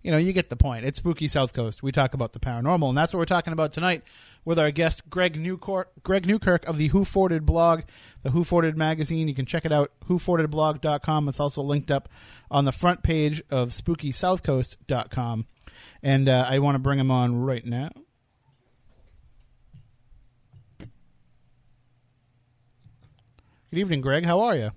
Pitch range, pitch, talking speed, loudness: 125-165 Hz, 145 Hz, 170 wpm, -24 LUFS